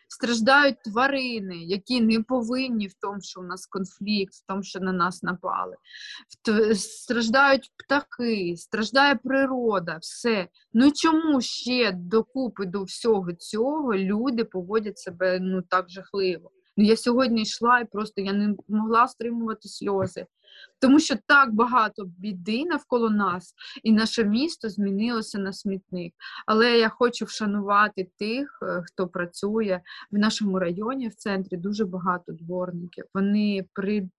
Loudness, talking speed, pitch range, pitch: -24 LUFS, 135 wpm, 195-245 Hz, 215 Hz